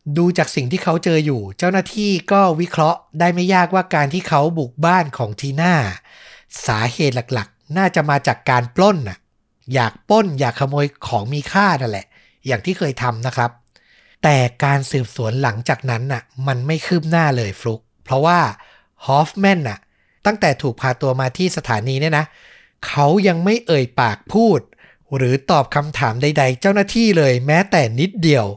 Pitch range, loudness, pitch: 125-175 Hz, -17 LUFS, 145 Hz